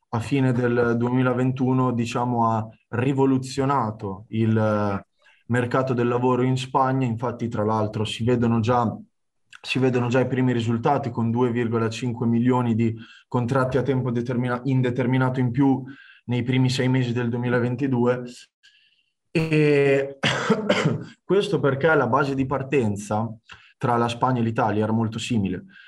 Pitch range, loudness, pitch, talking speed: 115-130 Hz, -23 LUFS, 125 Hz, 130 wpm